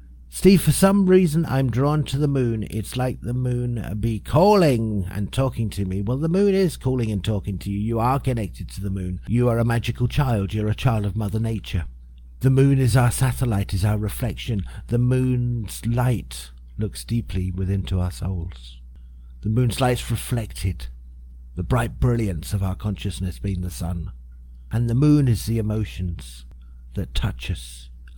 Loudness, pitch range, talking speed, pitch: -22 LUFS, 90-125 Hz, 180 wpm, 105 Hz